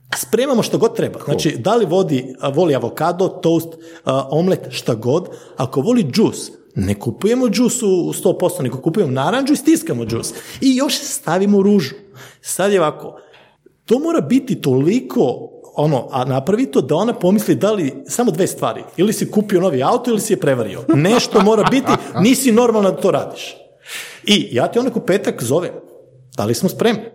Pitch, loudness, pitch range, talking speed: 190 Hz, -17 LUFS, 160-235 Hz, 170 wpm